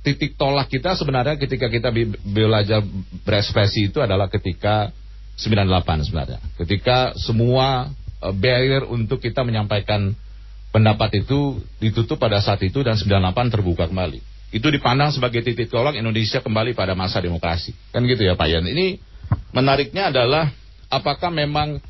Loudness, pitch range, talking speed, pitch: -20 LUFS, 100-130 Hz, 135 wpm, 110 Hz